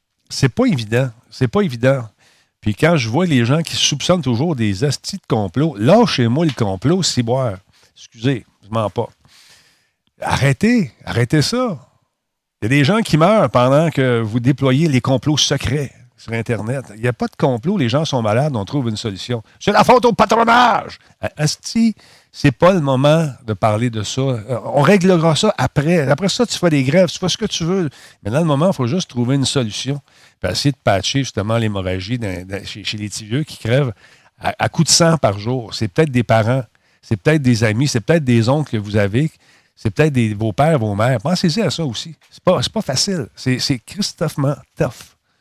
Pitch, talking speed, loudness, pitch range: 135 Hz, 205 wpm, -17 LUFS, 115-160 Hz